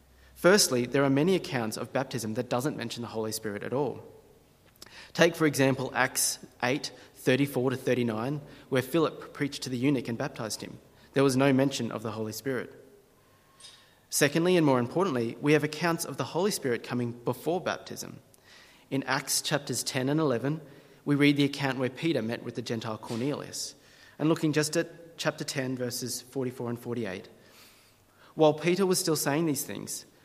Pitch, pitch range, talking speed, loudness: 135 Hz, 120-150 Hz, 175 wpm, -29 LUFS